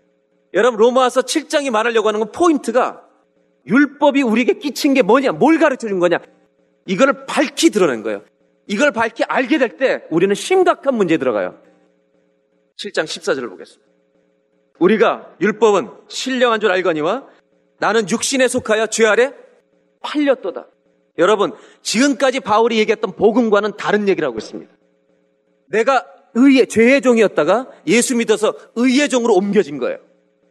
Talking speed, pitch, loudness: 320 characters per minute, 225 Hz, -16 LUFS